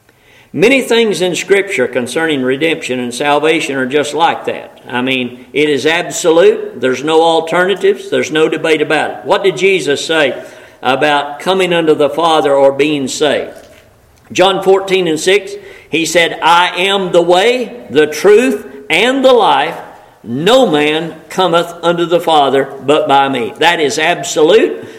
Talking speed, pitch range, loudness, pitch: 155 wpm, 150-195 Hz, -12 LUFS, 165 Hz